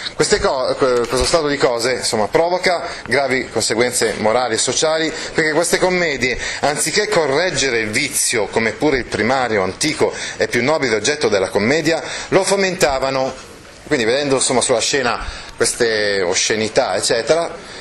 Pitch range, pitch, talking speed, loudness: 140-190 Hz, 165 Hz, 135 wpm, -17 LUFS